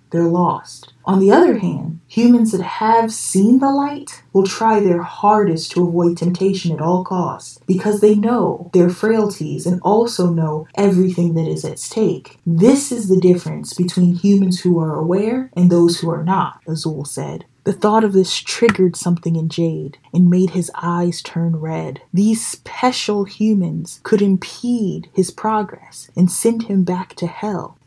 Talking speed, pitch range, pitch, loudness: 170 wpm, 170-210 Hz, 185 Hz, -17 LUFS